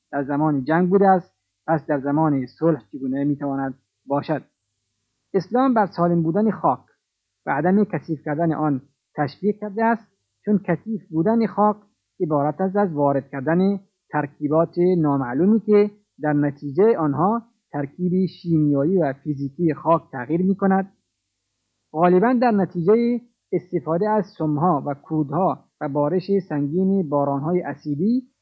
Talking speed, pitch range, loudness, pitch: 130 wpm, 145-195 Hz, -21 LUFS, 165 Hz